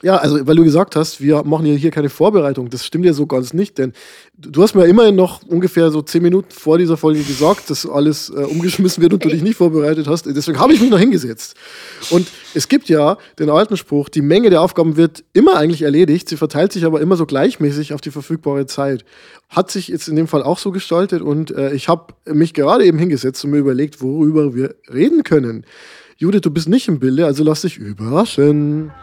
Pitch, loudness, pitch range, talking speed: 160 Hz, -14 LUFS, 145-175 Hz, 225 wpm